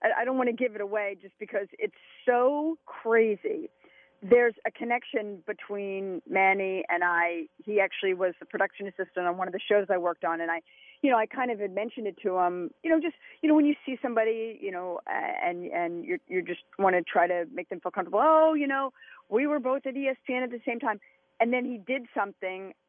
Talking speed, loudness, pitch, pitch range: 235 wpm, -28 LUFS, 220 Hz, 190-270 Hz